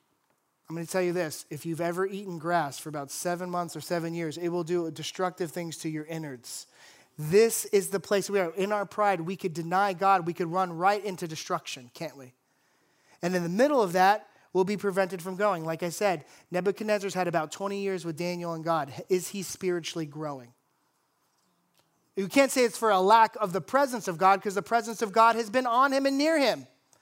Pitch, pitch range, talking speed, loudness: 180 Hz, 165-200 Hz, 220 wpm, -28 LUFS